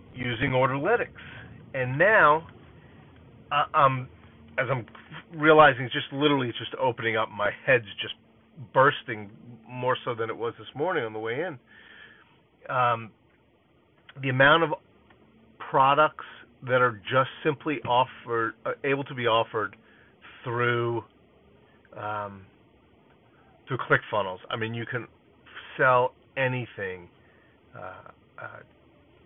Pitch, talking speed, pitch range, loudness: 125 Hz, 120 wpm, 115-135 Hz, -25 LUFS